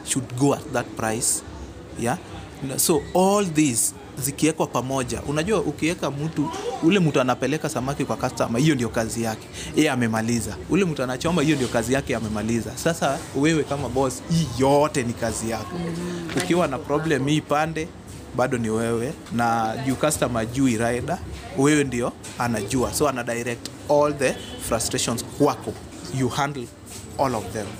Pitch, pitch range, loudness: 130 Hz, 115-150 Hz, -23 LUFS